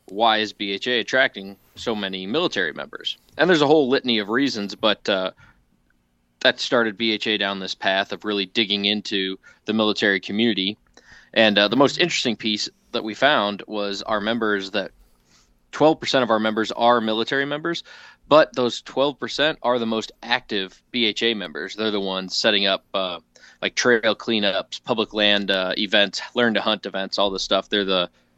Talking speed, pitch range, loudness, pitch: 170 wpm, 100-115 Hz, -21 LUFS, 105 Hz